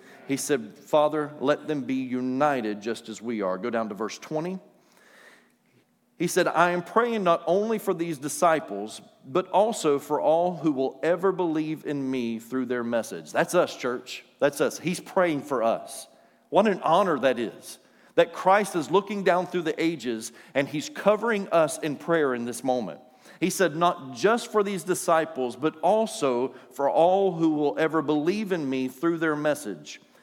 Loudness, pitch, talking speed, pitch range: -26 LUFS, 155 Hz, 180 wpm, 130-175 Hz